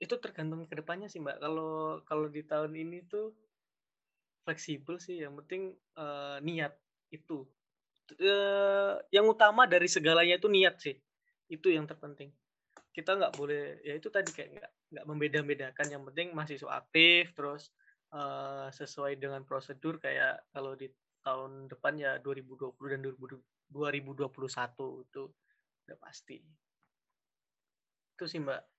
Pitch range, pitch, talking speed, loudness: 140-180 Hz, 155 Hz, 135 wpm, -32 LUFS